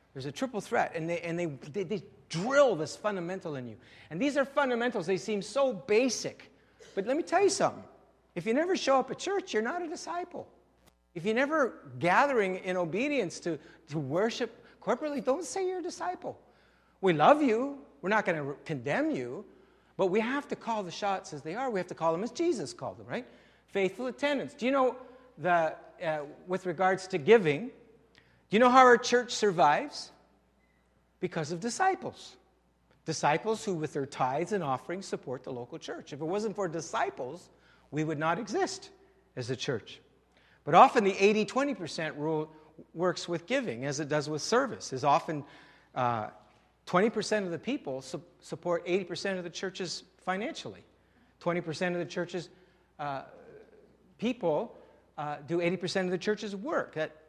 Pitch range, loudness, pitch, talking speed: 165-245 Hz, -30 LUFS, 190 Hz, 175 wpm